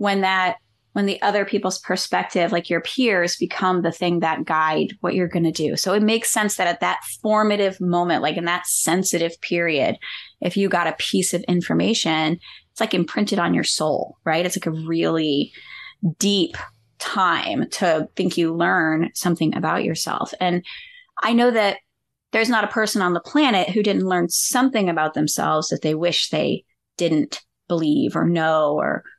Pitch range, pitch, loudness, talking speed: 165-205 Hz, 175 Hz, -21 LUFS, 175 wpm